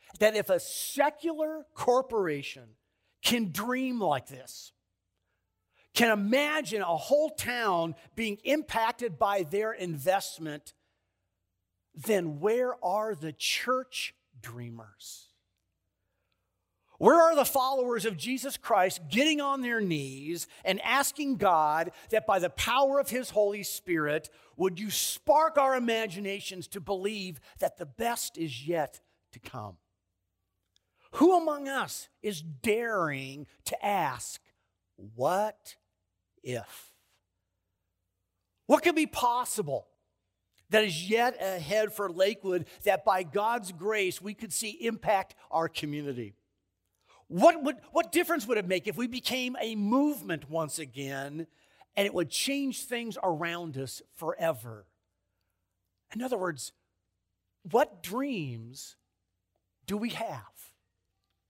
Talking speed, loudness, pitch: 115 wpm, -29 LUFS, 180 Hz